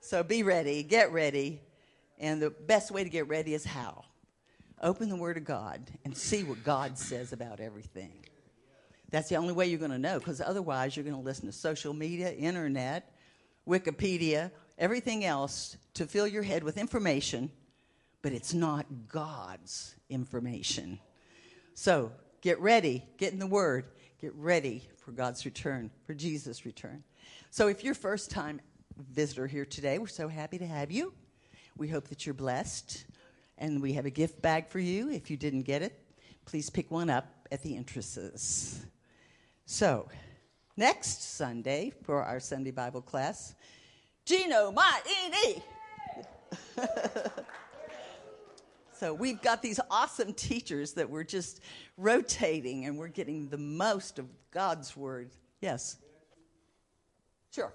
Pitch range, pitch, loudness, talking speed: 135-180 Hz, 150 Hz, -33 LUFS, 150 wpm